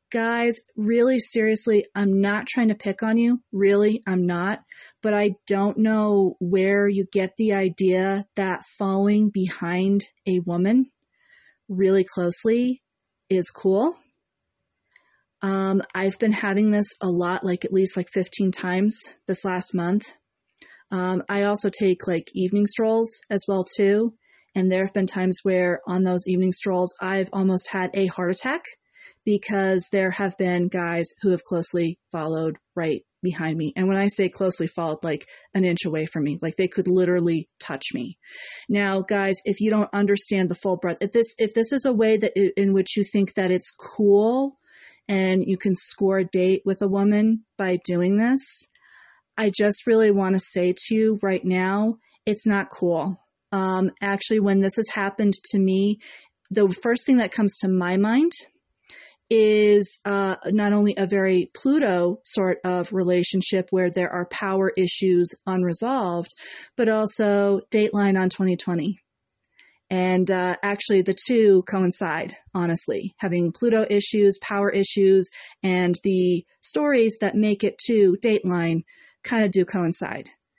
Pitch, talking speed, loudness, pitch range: 195 Hz, 160 wpm, -22 LUFS, 185-210 Hz